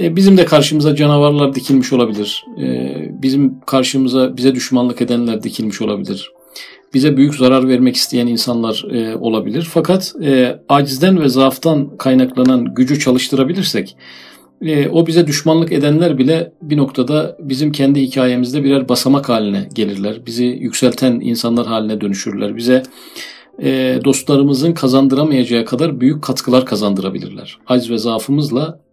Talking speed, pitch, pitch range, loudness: 115 wpm, 130 Hz, 120-145 Hz, -14 LUFS